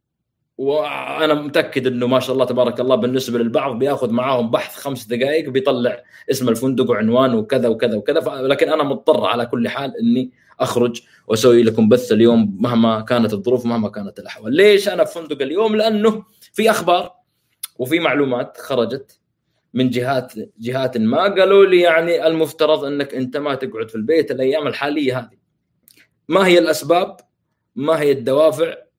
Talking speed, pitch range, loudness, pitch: 155 wpm, 125-175 Hz, -17 LUFS, 140 Hz